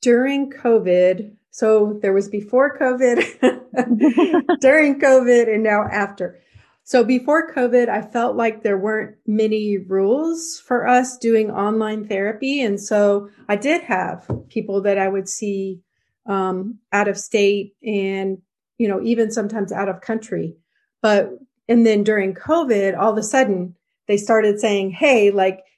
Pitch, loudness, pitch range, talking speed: 215 Hz, -18 LUFS, 200-245 Hz, 145 wpm